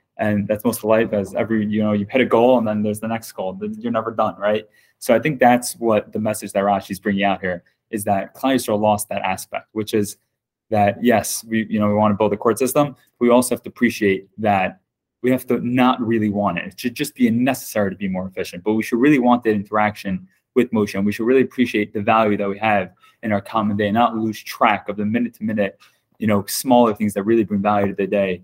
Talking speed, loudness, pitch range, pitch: 250 wpm, -19 LUFS, 105-120 Hz, 110 Hz